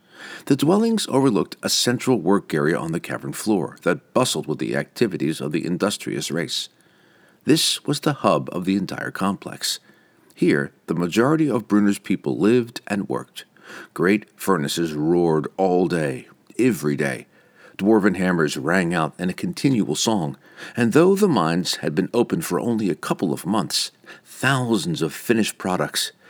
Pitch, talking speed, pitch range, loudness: 100 Hz, 155 wpm, 90-125 Hz, -21 LUFS